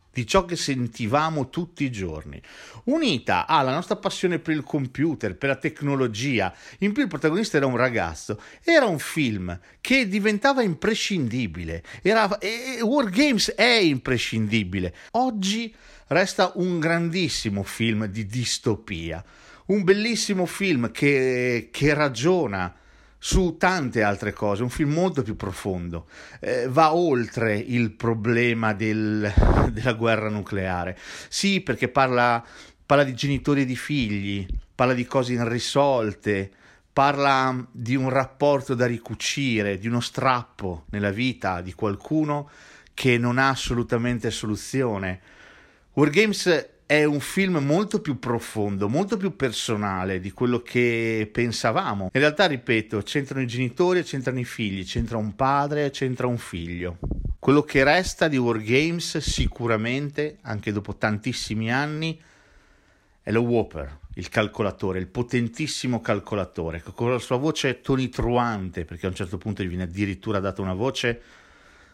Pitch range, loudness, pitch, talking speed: 105-150 Hz, -24 LUFS, 125 Hz, 135 wpm